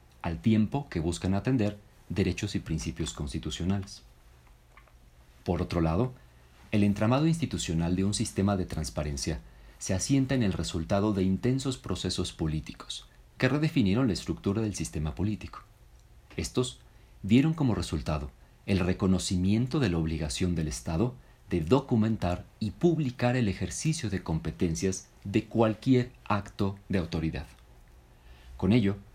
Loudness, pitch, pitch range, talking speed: -29 LUFS, 95 Hz, 80-110 Hz, 130 wpm